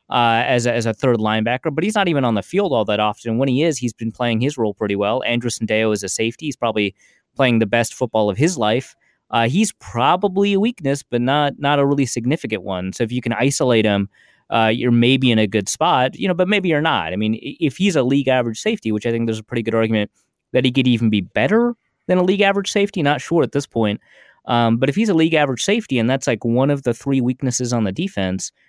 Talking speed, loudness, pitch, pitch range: 255 wpm, -18 LUFS, 125 Hz, 110-145 Hz